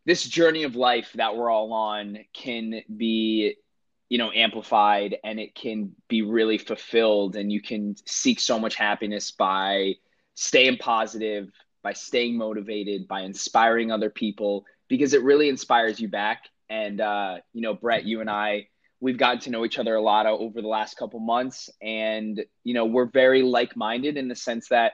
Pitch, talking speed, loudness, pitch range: 110 Hz, 175 wpm, -24 LUFS, 105-120 Hz